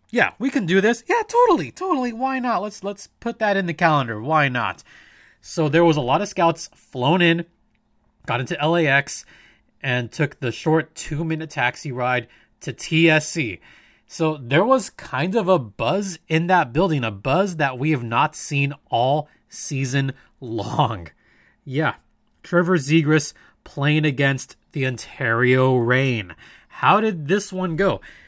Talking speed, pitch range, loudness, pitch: 155 wpm, 130-185 Hz, -21 LUFS, 155 Hz